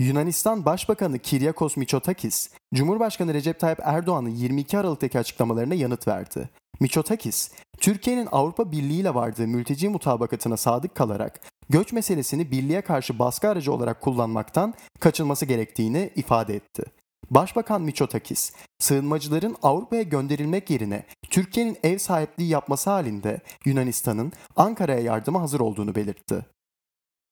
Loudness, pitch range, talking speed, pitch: -24 LUFS, 125-180 Hz, 110 wpm, 150 Hz